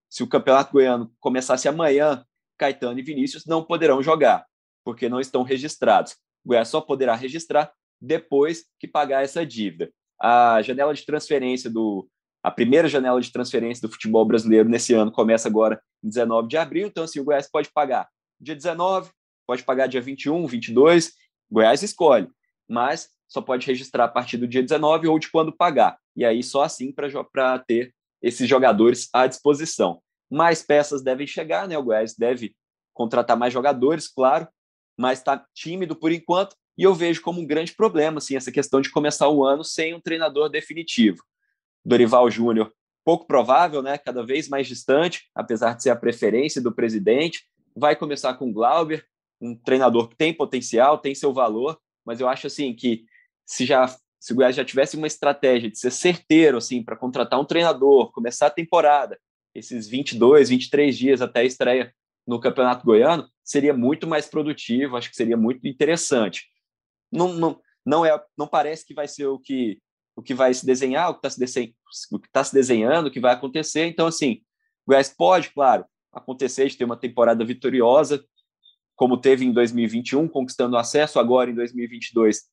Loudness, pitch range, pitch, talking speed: -21 LUFS, 120-155 Hz, 135 Hz, 175 wpm